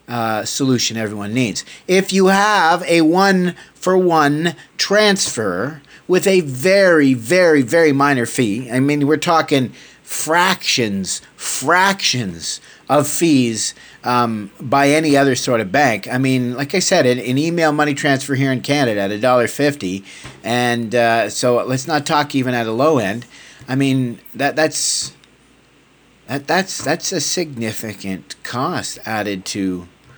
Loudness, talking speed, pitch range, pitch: -16 LUFS, 145 wpm, 120-155 Hz, 140 Hz